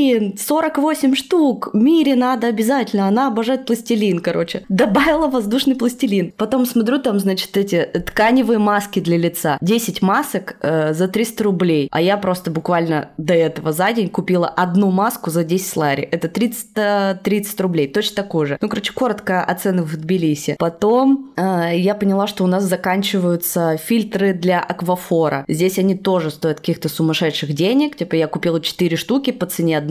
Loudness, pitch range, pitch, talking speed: -17 LUFS, 170-230 Hz, 190 Hz, 160 wpm